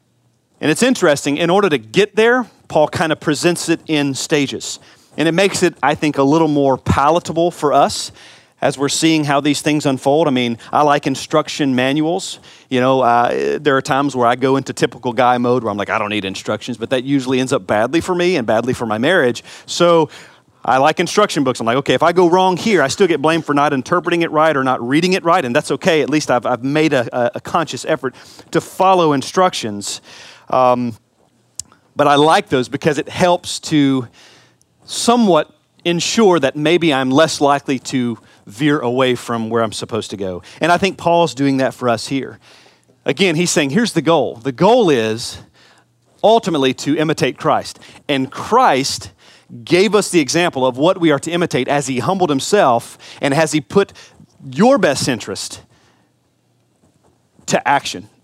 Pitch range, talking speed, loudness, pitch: 130-170 Hz, 195 wpm, -15 LUFS, 145 Hz